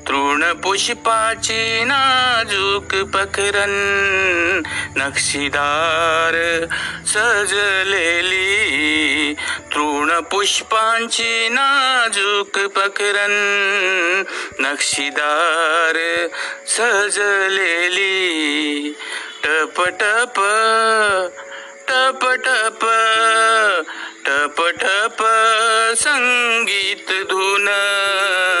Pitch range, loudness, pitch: 170-225 Hz, -16 LUFS, 200 Hz